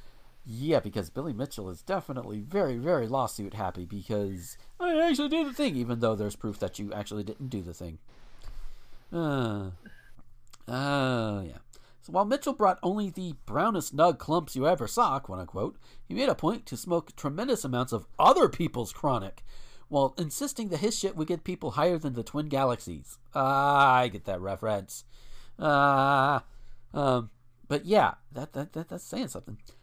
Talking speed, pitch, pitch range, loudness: 165 wpm, 130 Hz, 110-155 Hz, -29 LUFS